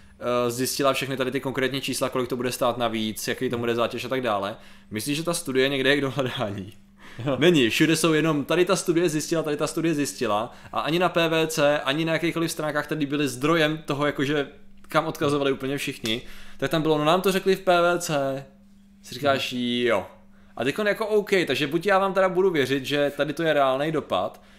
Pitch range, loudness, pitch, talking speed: 130-165 Hz, -24 LUFS, 145 Hz, 205 wpm